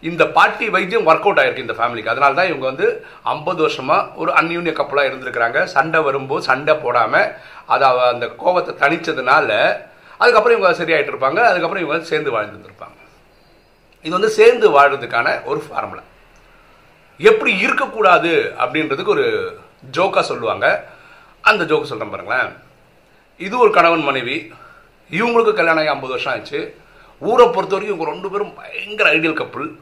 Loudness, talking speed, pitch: -16 LUFS, 130 wpm, 205 Hz